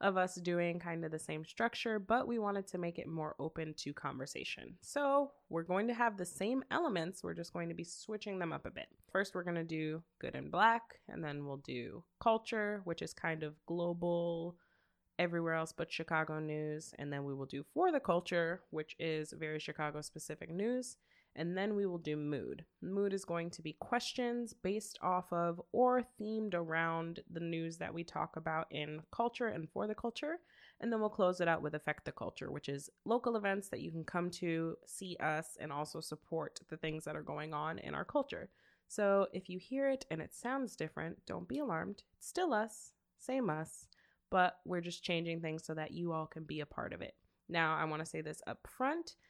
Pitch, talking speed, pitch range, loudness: 170 Hz, 215 wpm, 160-210 Hz, -39 LUFS